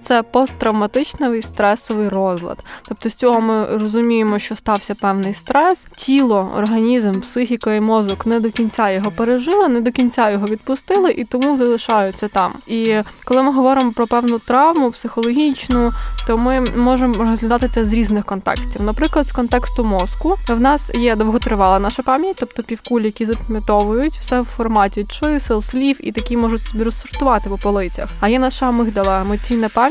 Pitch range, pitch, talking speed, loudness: 215-255 Hz, 230 Hz, 160 wpm, -17 LUFS